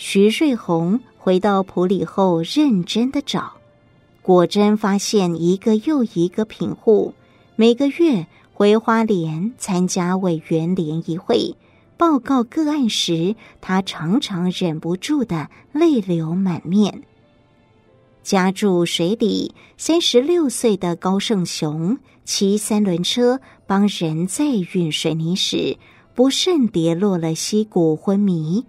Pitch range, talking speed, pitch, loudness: 170-230 Hz, 175 characters per minute, 195 Hz, -19 LUFS